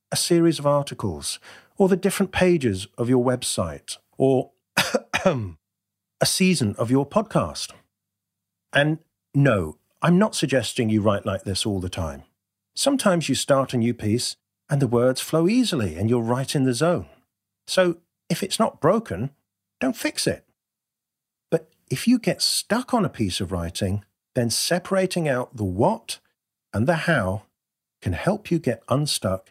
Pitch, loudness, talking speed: 130 Hz, -23 LUFS, 155 wpm